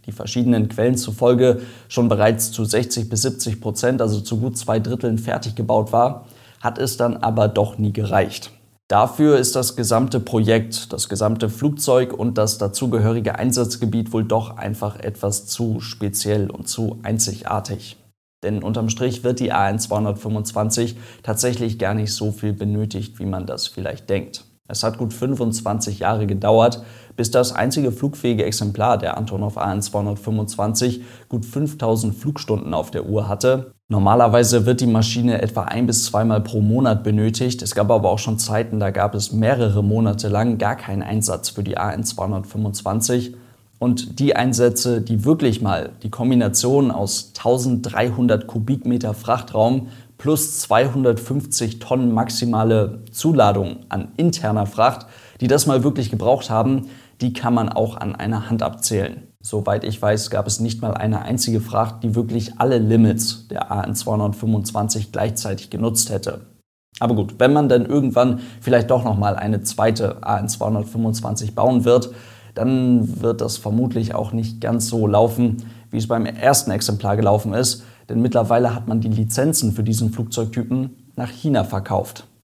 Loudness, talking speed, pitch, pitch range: -20 LUFS, 155 wpm, 115 Hz, 105-120 Hz